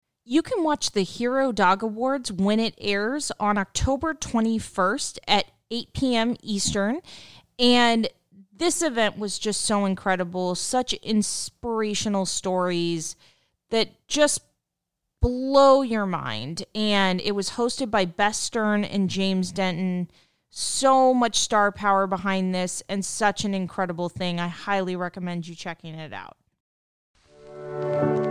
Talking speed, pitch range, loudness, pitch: 125 wpm, 180-230 Hz, -24 LUFS, 200 Hz